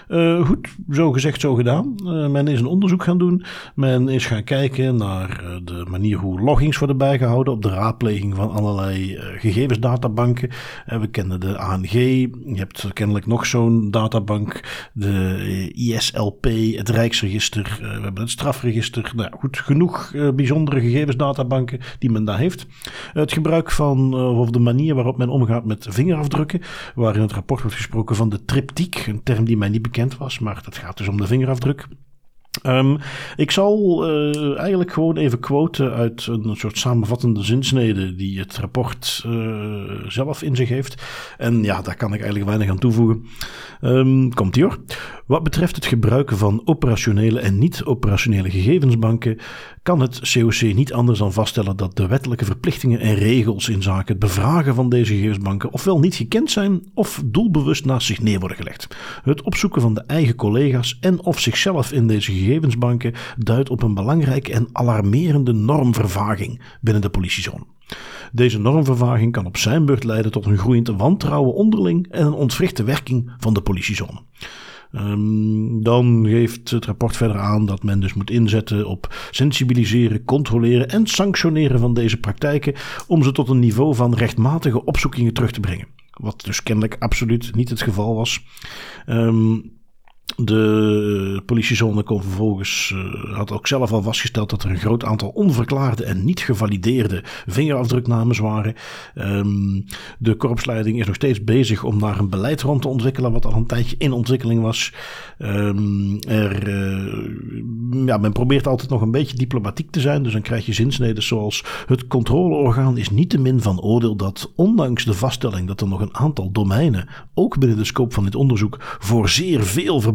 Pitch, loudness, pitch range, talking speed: 120 Hz, -19 LUFS, 105-135 Hz, 170 wpm